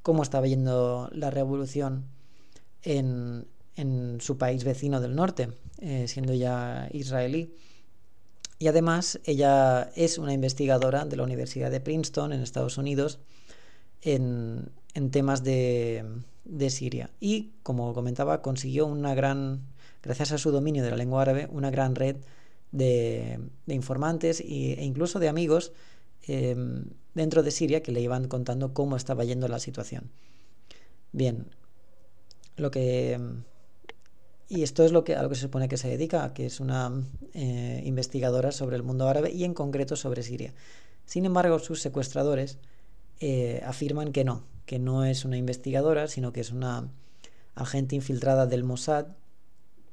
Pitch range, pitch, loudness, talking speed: 125-145 Hz, 135 Hz, -28 LUFS, 150 wpm